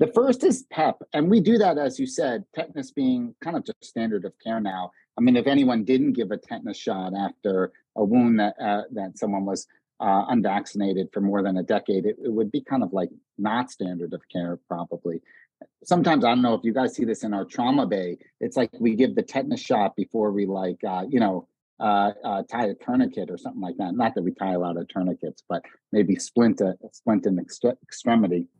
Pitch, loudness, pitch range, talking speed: 110 Hz, -25 LUFS, 95-160 Hz, 225 wpm